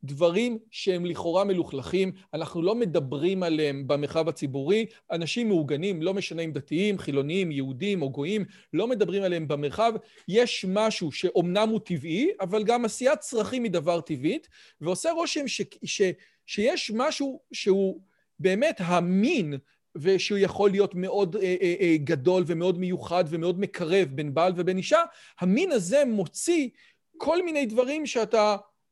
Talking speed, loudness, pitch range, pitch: 145 wpm, -26 LUFS, 170-220 Hz, 190 Hz